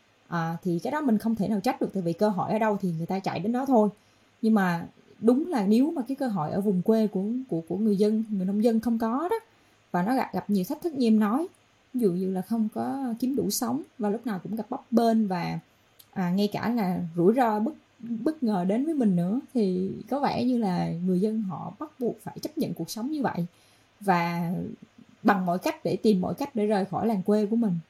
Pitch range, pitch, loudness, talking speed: 185-245 Hz, 215 Hz, -27 LUFS, 250 wpm